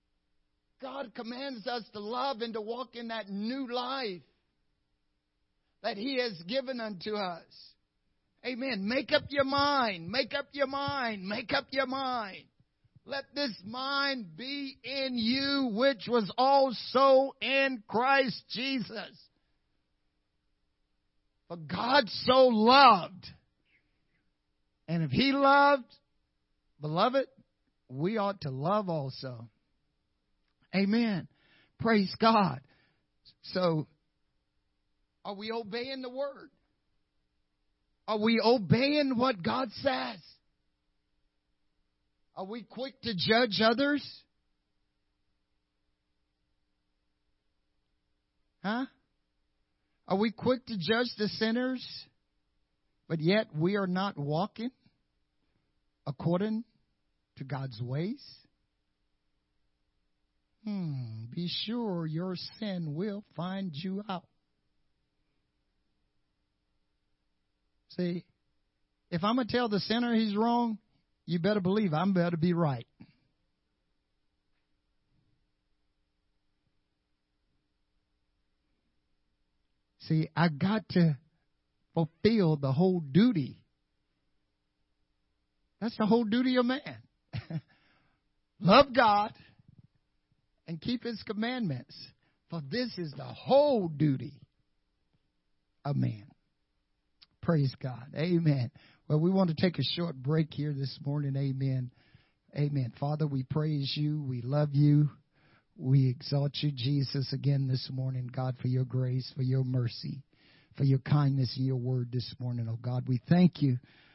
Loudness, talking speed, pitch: -30 LUFS, 105 wpm, 165 Hz